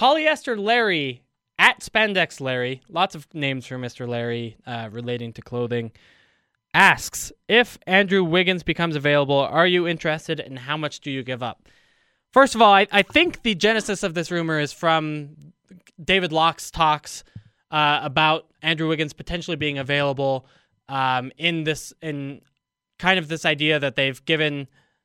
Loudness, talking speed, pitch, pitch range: -21 LUFS, 155 wpm, 155 Hz, 135-180 Hz